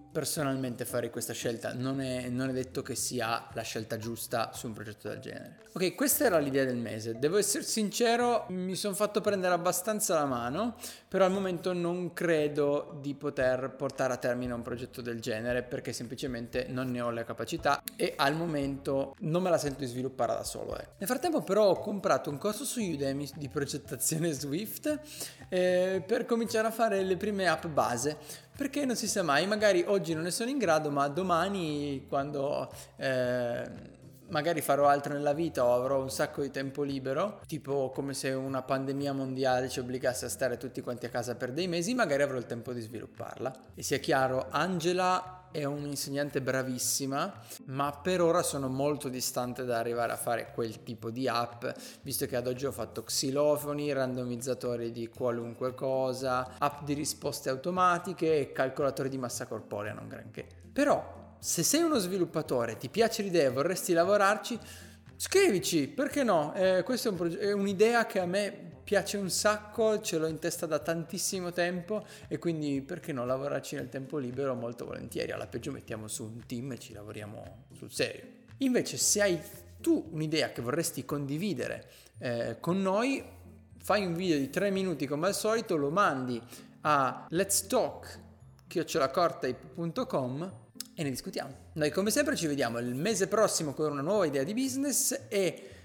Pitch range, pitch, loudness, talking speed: 125-185 Hz, 145 Hz, -31 LUFS, 175 wpm